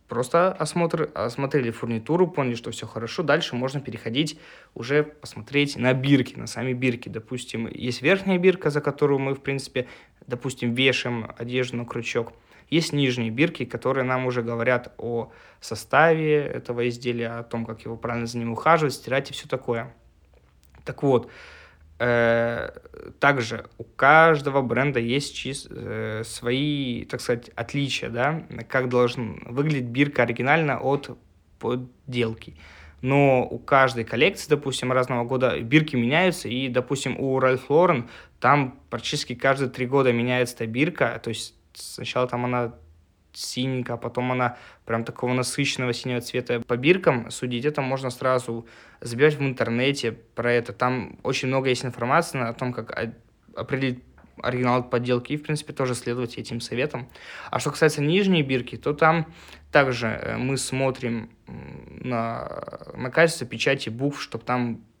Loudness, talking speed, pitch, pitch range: -24 LUFS, 145 wpm, 125 Hz, 120-140 Hz